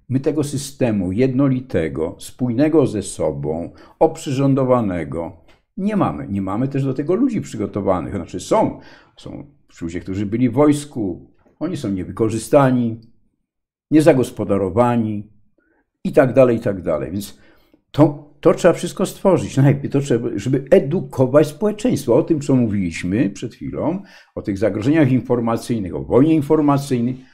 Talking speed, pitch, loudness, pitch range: 125 wpm, 130 Hz, -18 LUFS, 110-150 Hz